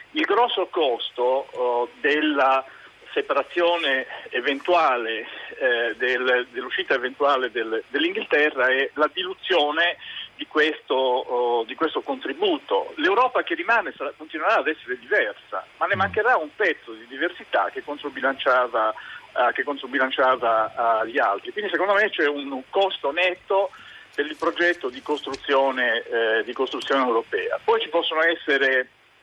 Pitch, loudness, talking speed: 160 Hz, -23 LUFS, 125 wpm